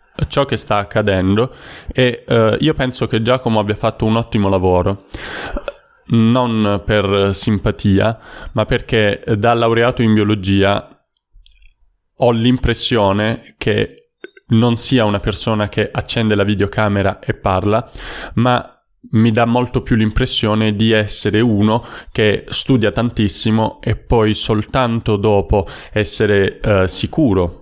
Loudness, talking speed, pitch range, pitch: -16 LUFS, 120 wpm, 100-120 Hz, 110 Hz